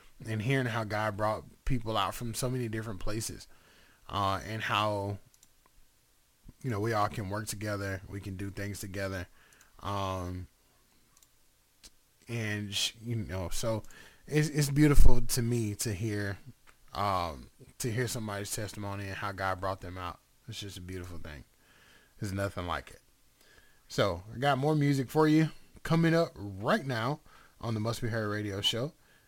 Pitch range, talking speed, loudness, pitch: 100-125 Hz, 160 wpm, -33 LUFS, 105 Hz